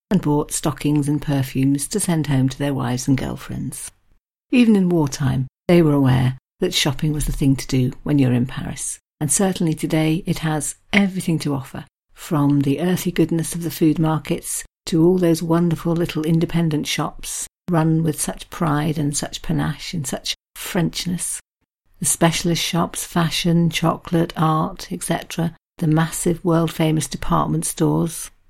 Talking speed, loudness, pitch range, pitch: 160 wpm, -20 LUFS, 145-170 Hz, 160 Hz